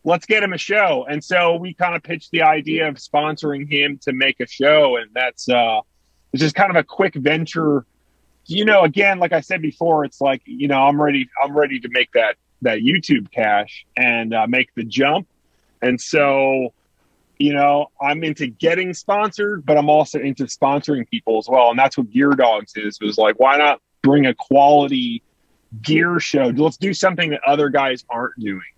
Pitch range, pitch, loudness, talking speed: 130-165 Hz, 145 Hz, -17 LUFS, 200 wpm